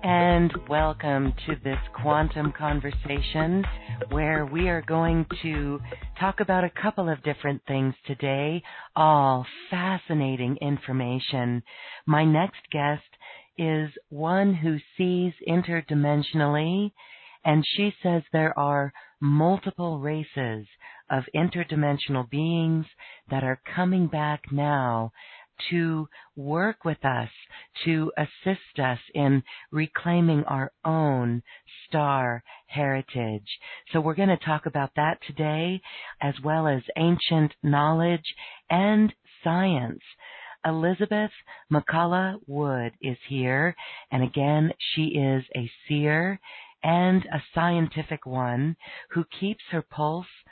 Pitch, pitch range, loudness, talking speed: 155 Hz, 140-170 Hz, -26 LUFS, 110 wpm